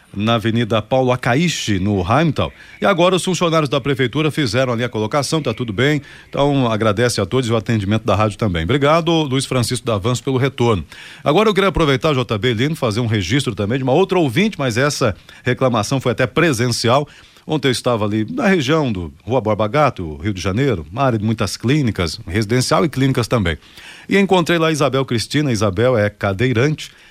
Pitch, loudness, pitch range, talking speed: 125 Hz, -17 LUFS, 110-145 Hz, 190 wpm